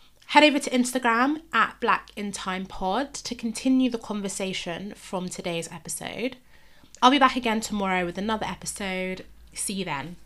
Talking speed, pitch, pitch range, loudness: 140 wpm, 205 Hz, 185-250 Hz, -25 LUFS